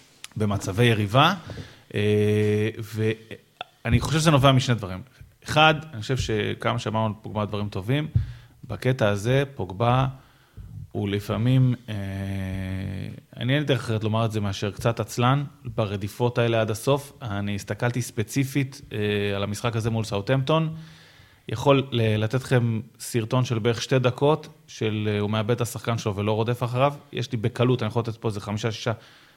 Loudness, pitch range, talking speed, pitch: -25 LUFS, 105-130 Hz, 145 wpm, 115 Hz